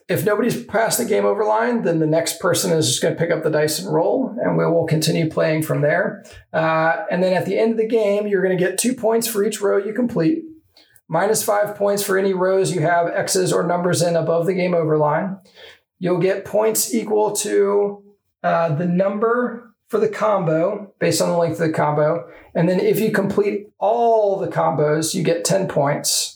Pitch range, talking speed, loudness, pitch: 165-210 Hz, 215 wpm, -19 LUFS, 190 Hz